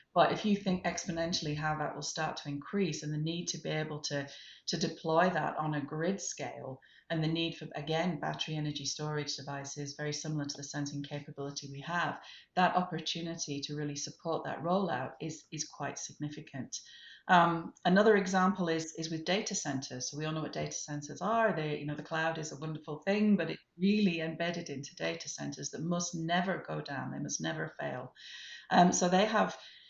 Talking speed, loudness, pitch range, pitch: 195 wpm, -34 LUFS, 145-175 Hz, 155 Hz